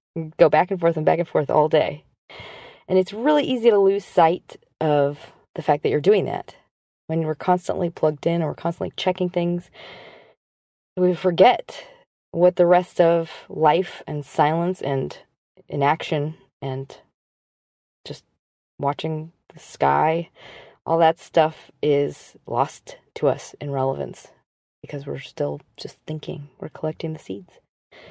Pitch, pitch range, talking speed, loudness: 160 Hz, 145-180 Hz, 145 wpm, -22 LUFS